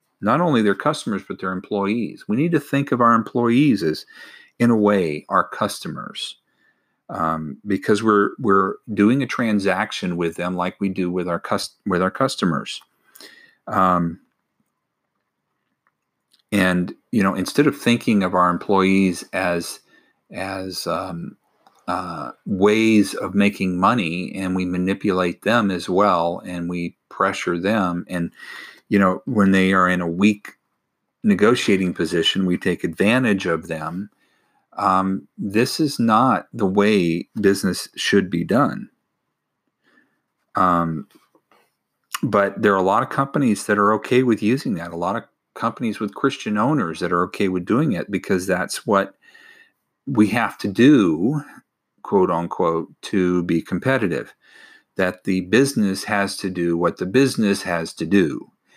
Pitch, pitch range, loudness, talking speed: 95 Hz, 90-110 Hz, -20 LUFS, 145 wpm